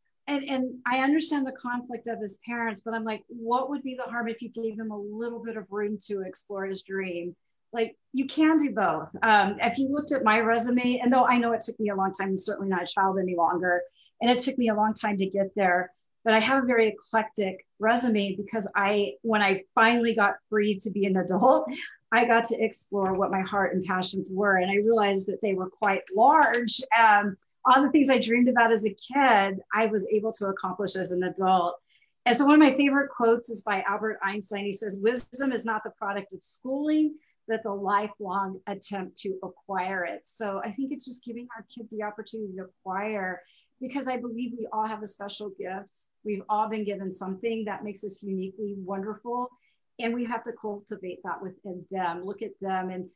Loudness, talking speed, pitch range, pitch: -26 LUFS, 220 wpm, 195-235 Hz, 215 Hz